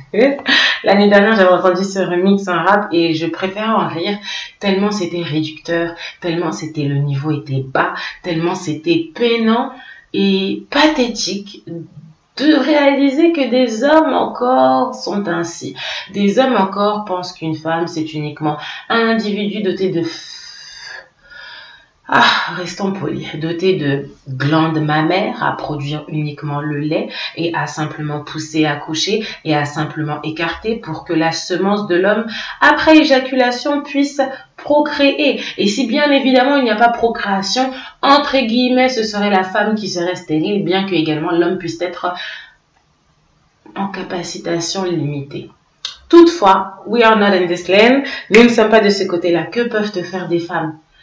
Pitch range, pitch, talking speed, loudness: 165-225 Hz, 185 Hz, 150 wpm, -15 LUFS